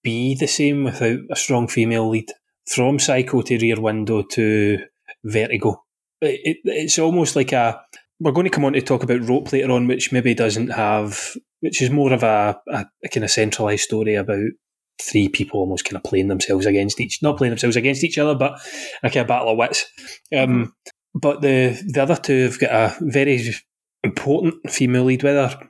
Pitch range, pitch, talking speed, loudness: 115-145 Hz, 130 Hz, 200 wpm, -19 LUFS